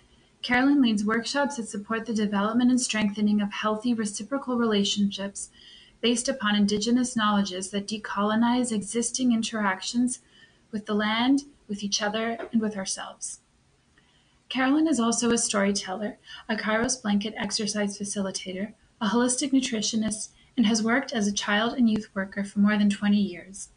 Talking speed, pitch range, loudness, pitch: 145 wpm, 205-235 Hz, -26 LUFS, 215 Hz